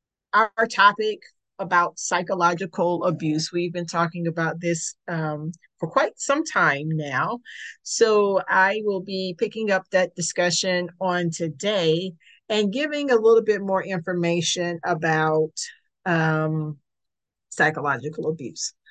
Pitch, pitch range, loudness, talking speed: 175 Hz, 160-205 Hz, -23 LUFS, 115 wpm